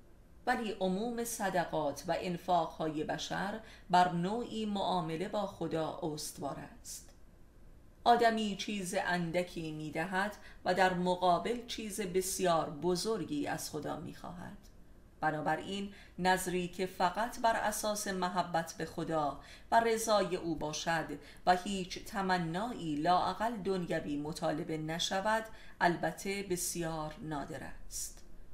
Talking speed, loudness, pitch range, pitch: 110 wpm, -34 LUFS, 160-200 Hz, 180 Hz